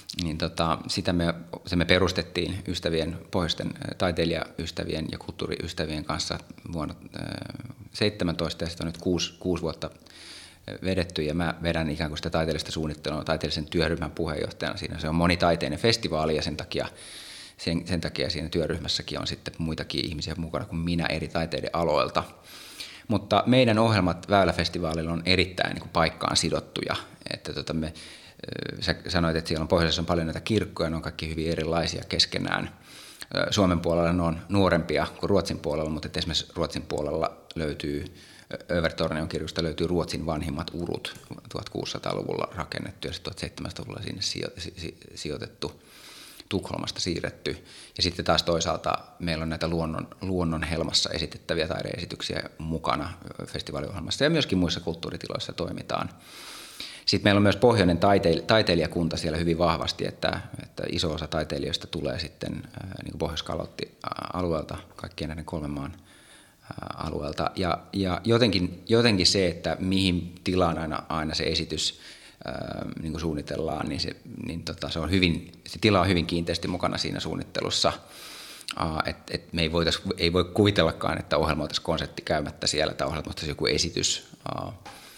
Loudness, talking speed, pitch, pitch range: -27 LUFS, 145 wpm, 85 Hz, 80-90 Hz